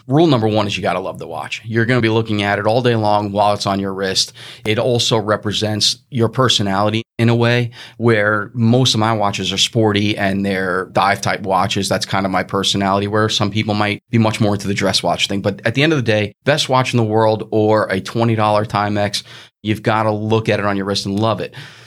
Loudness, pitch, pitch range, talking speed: -16 LUFS, 110 Hz, 100-115 Hz, 240 wpm